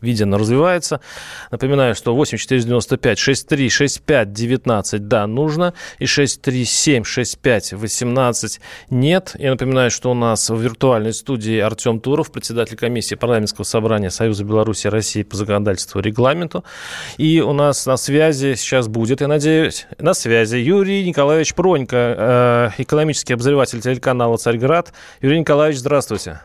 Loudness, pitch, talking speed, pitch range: -17 LUFS, 125 Hz, 120 wpm, 115-145 Hz